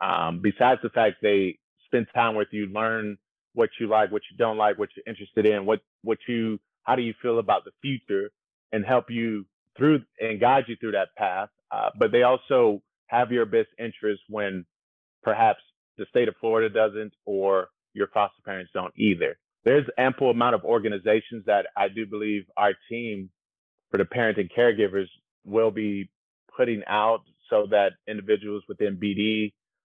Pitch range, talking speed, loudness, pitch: 100-115 Hz, 175 wpm, -25 LUFS, 110 Hz